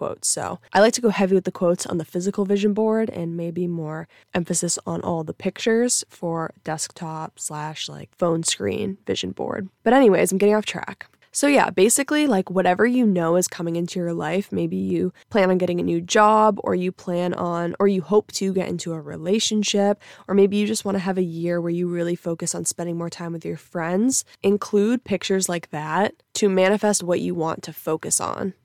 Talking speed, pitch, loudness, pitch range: 210 wpm, 185 Hz, -22 LUFS, 170-205 Hz